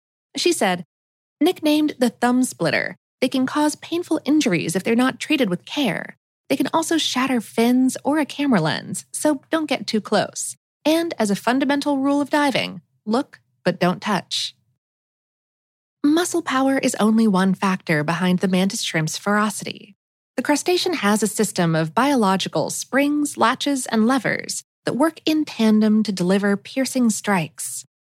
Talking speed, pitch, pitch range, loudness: 155 wpm, 245 Hz, 195-285 Hz, -20 LUFS